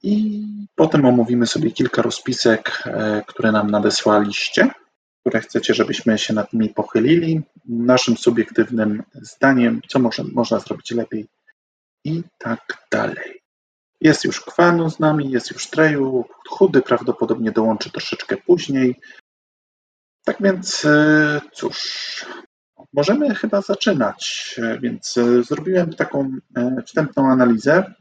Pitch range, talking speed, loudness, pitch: 115-170 Hz, 110 wpm, -18 LUFS, 135 Hz